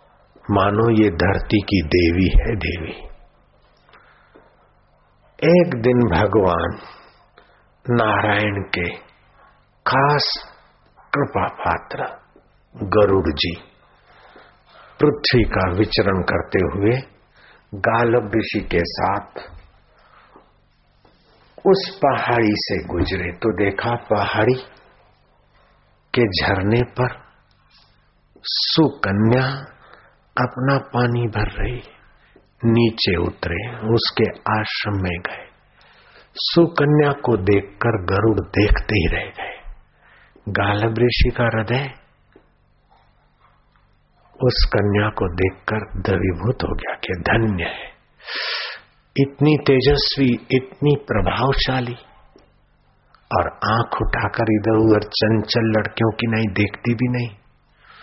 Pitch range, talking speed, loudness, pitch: 100-125 Hz, 90 wpm, -19 LUFS, 110 Hz